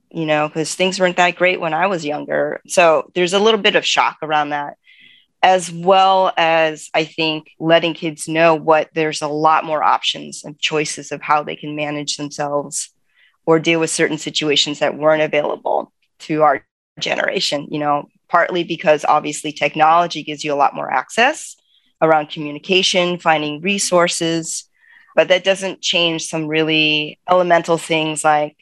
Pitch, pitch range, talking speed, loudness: 160 Hz, 150-175 Hz, 165 wpm, -17 LUFS